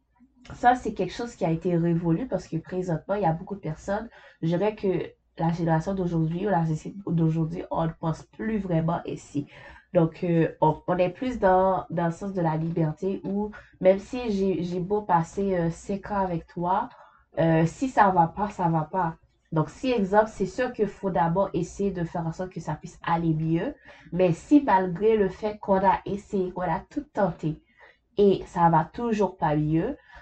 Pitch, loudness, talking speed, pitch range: 180 Hz, -26 LUFS, 210 wpm, 165-200 Hz